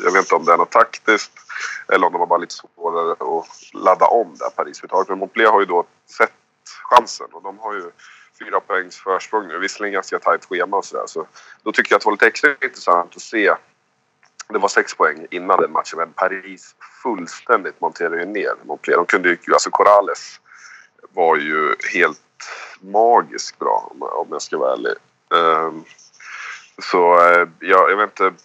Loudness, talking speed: -17 LUFS, 185 wpm